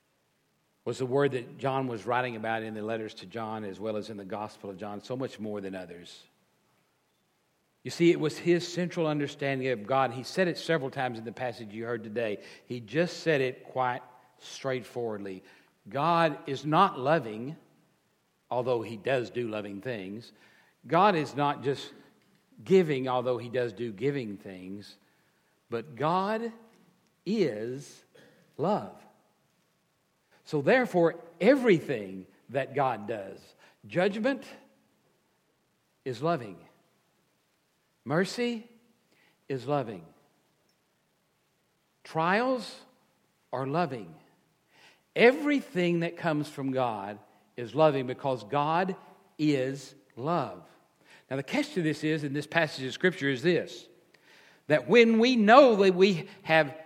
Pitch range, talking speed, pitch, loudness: 120-175 Hz, 130 wpm, 140 Hz, -29 LUFS